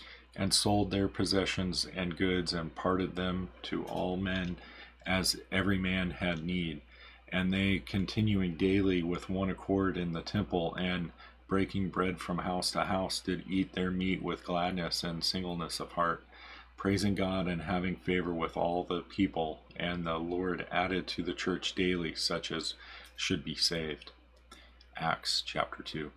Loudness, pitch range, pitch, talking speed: -33 LUFS, 85-95 Hz, 90 Hz, 160 wpm